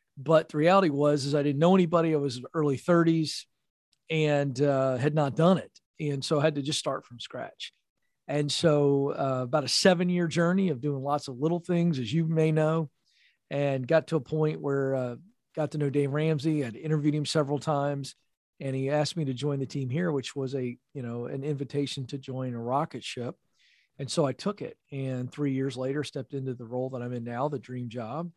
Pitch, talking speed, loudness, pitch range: 145 Hz, 220 wpm, -28 LUFS, 135-160 Hz